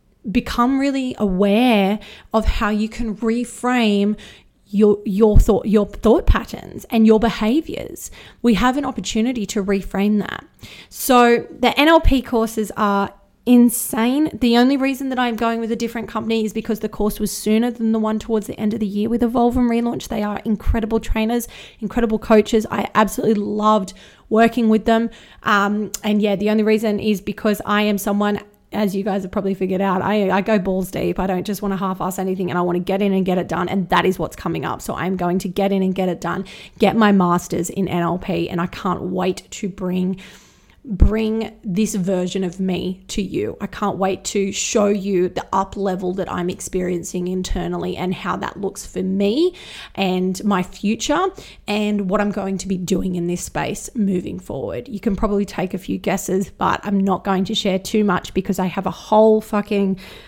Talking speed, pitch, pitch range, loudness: 200 wpm, 205 Hz, 190-220 Hz, -19 LUFS